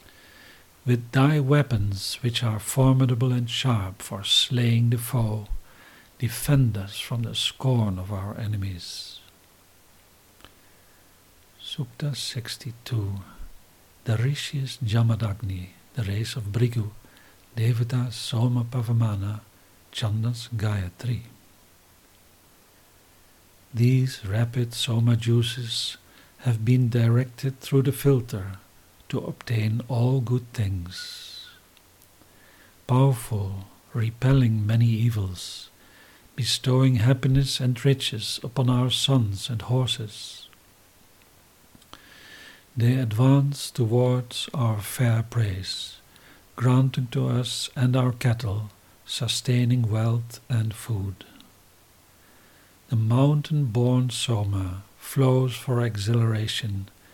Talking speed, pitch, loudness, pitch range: 90 wpm, 115 Hz, -25 LUFS, 100-125 Hz